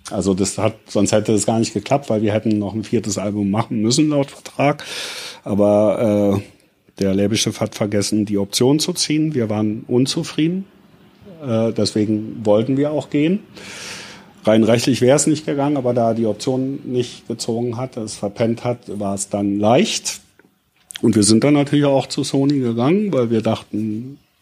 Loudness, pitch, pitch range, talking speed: -18 LUFS, 115 Hz, 105-140 Hz, 175 wpm